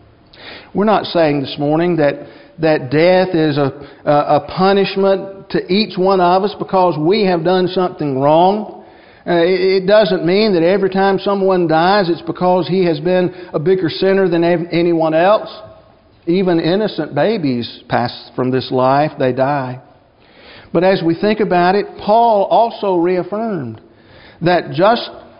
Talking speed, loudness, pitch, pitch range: 145 wpm, -14 LUFS, 175 Hz, 150-190 Hz